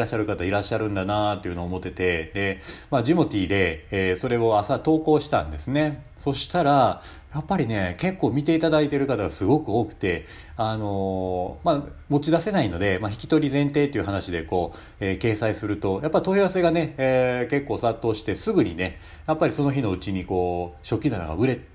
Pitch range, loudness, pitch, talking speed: 95-145 Hz, -24 LUFS, 110 Hz, 425 characters per minute